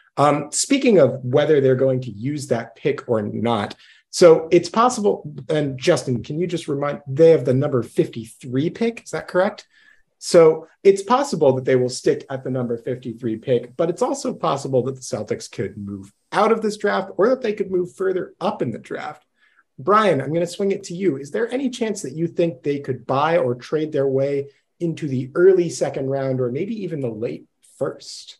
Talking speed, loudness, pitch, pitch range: 205 wpm, -20 LUFS, 150 Hz, 130-185 Hz